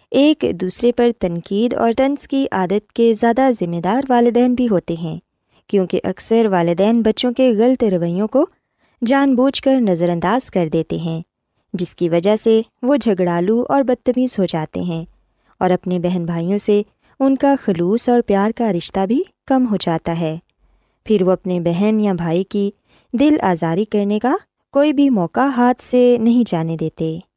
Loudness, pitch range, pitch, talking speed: -17 LUFS, 180-250 Hz, 210 Hz, 175 wpm